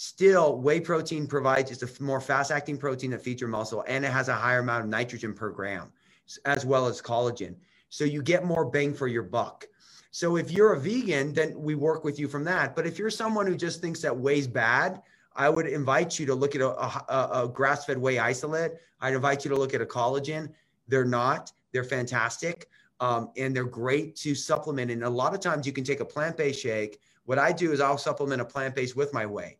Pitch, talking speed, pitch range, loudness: 140 Hz, 225 wpm, 125-155 Hz, -28 LUFS